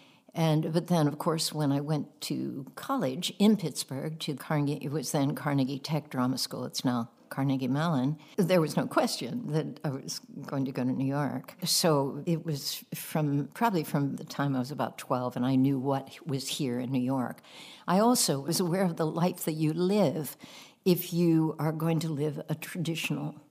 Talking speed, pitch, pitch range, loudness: 195 wpm, 155 Hz, 135-170 Hz, -30 LUFS